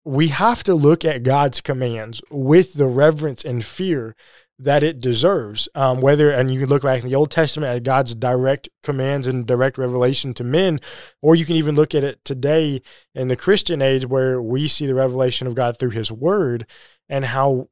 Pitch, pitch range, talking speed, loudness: 135 Hz, 125-150 Hz, 200 wpm, -18 LUFS